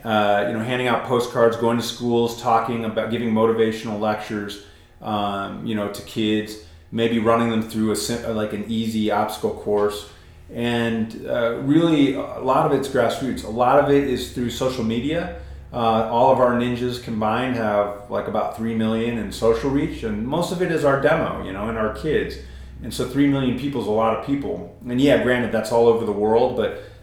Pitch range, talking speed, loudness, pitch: 105-125 Hz, 200 wpm, -21 LUFS, 115 Hz